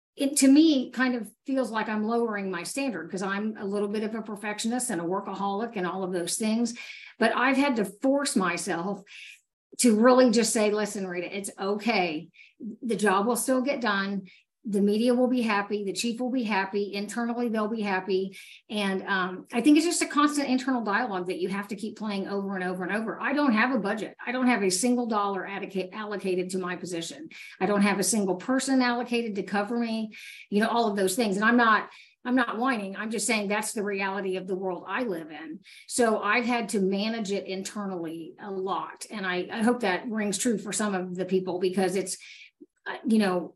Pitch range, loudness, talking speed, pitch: 195-240 Hz, -27 LUFS, 215 wpm, 210 Hz